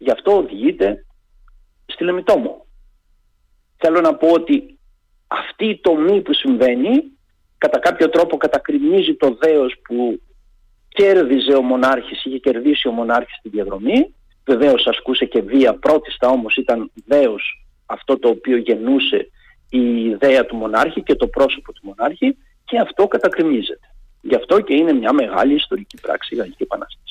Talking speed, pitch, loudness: 145 wpm, 165 Hz, -17 LUFS